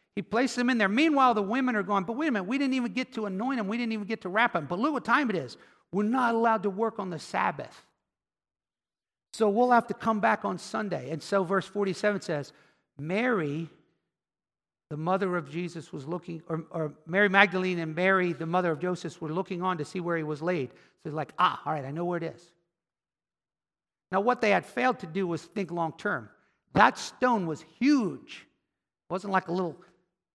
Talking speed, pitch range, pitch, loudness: 220 wpm, 170-225 Hz, 190 Hz, -28 LUFS